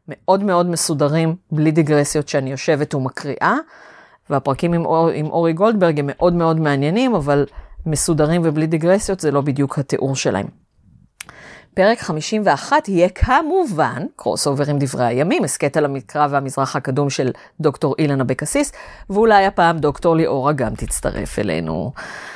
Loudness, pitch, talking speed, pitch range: -18 LUFS, 155 Hz, 140 wpm, 140-175 Hz